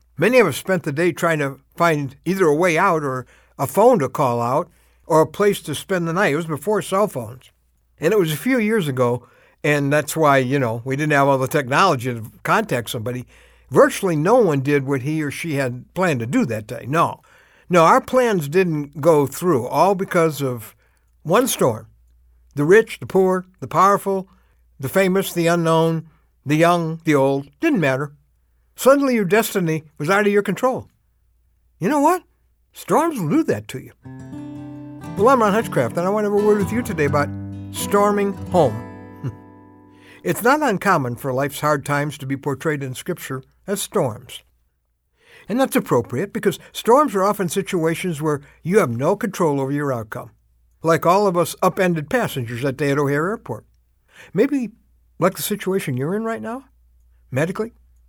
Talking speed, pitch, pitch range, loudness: 185 wpm, 155 Hz, 130-195 Hz, -19 LUFS